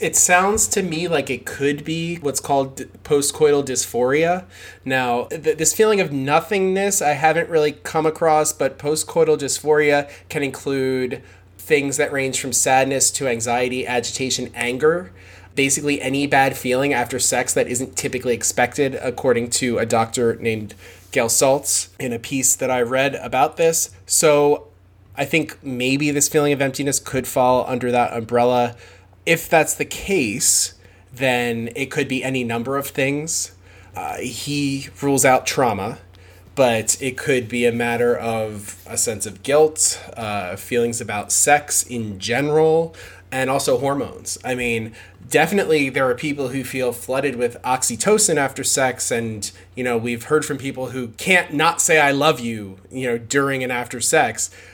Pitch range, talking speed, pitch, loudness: 115-145 Hz, 160 wpm, 130 Hz, -19 LUFS